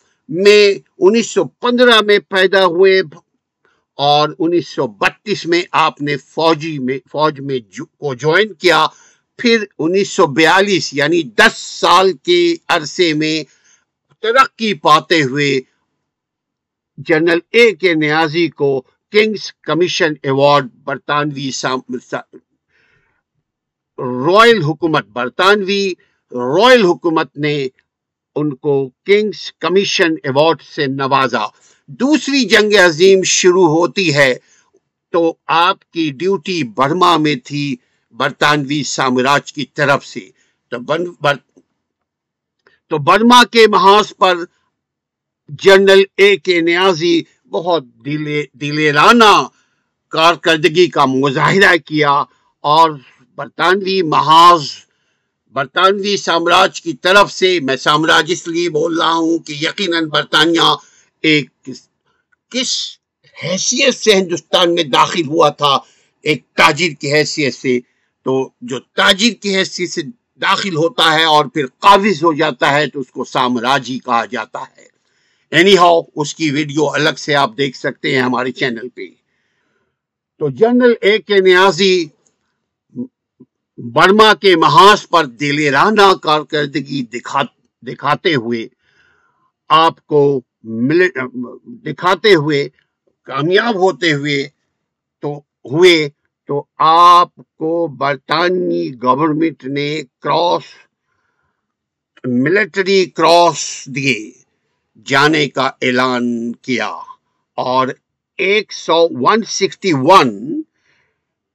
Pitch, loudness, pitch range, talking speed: 165 Hz, -13 LUFS, 145-195 Hz, 100 wpm